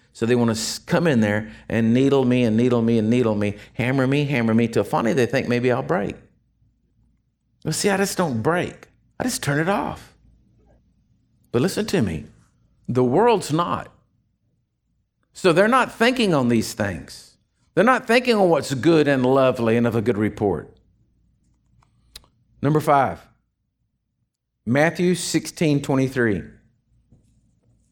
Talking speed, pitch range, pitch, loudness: 150 wpm, 115-155 Hz, 125 Hz, -20 LUFS